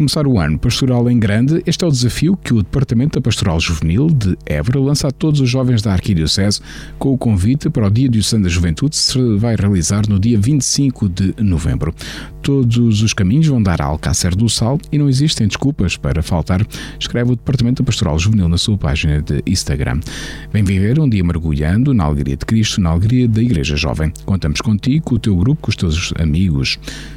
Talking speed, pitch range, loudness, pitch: 205 wpm, 90-130 Hz, -15 LUFS, 110 Hz